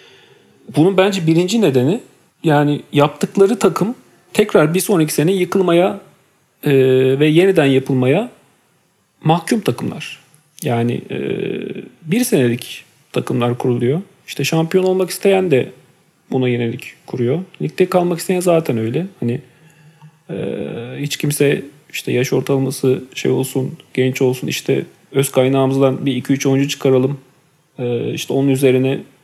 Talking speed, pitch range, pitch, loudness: 125 wpm, 130-175 Hz, 145 Hz, -17 LUFS